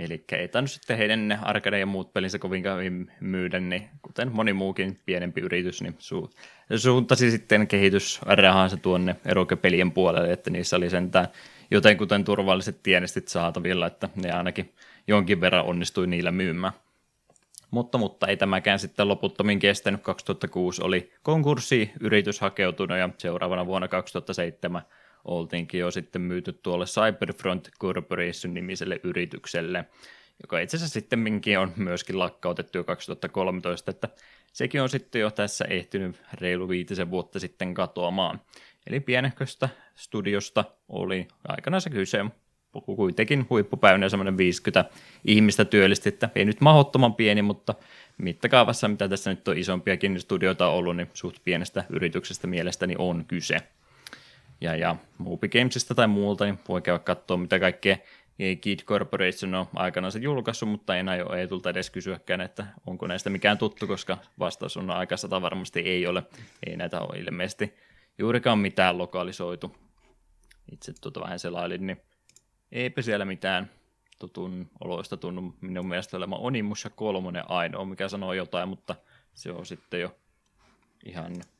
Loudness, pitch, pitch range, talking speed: -26 LUFS, 95 Hz, 90-105 Hz, 140 wpm